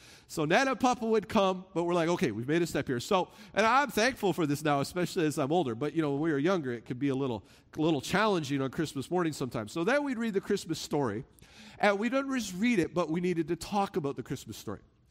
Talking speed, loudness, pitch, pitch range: 260 wpm, -30 LUFS, 170 Hz, 145-205 Hz